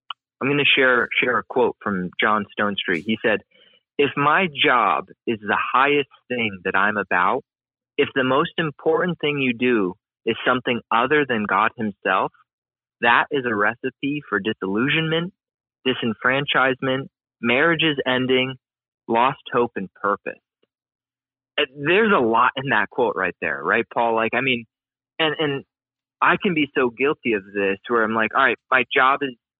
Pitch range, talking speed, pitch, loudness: 115-145 Hz, 160 wpm, 130 Hz, -20 LUFS